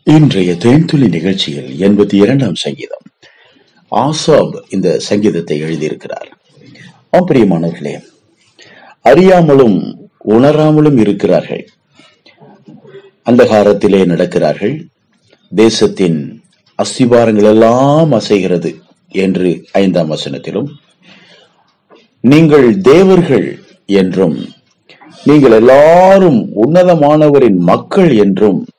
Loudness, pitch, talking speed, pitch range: -9 LUFS, 110 Hz, 60 wpm, 95-155 Hz